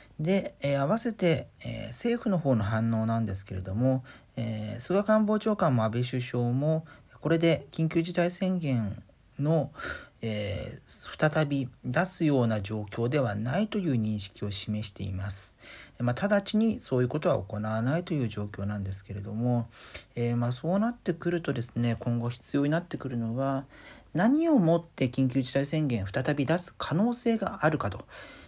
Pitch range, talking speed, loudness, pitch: 115-165 Hz, 320 characters per minute, -29 LUFS, 130 Hz